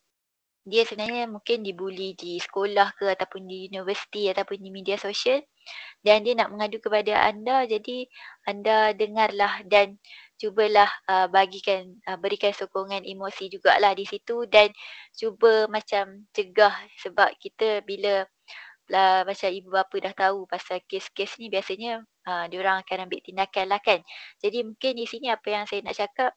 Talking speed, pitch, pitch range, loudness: 155 wpm, 200 Hz, 195-220 Hz, -25 LUFS